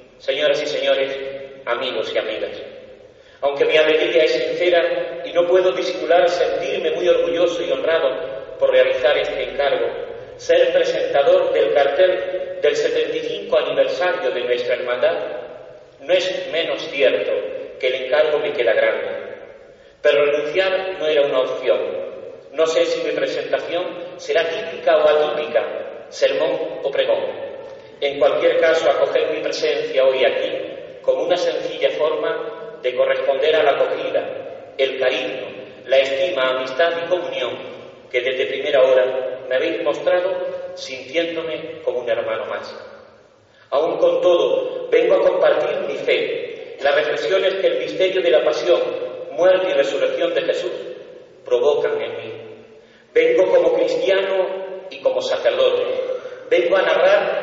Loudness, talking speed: -19 LUFS, 135 wpm